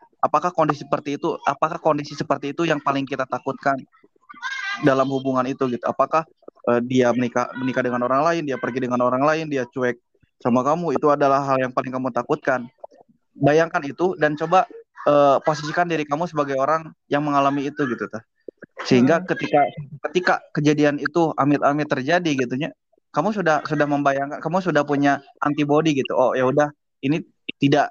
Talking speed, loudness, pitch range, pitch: 165 wpm, -21 LUFS, 135-160 Hz, 145 Hz